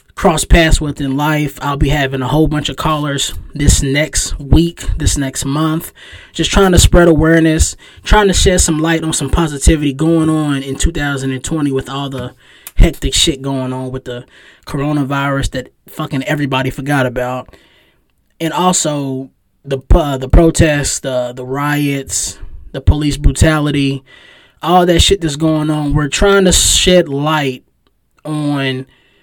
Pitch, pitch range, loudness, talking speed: 140 Hz, 130-155 Hz, -13 LUFS, 155 wpm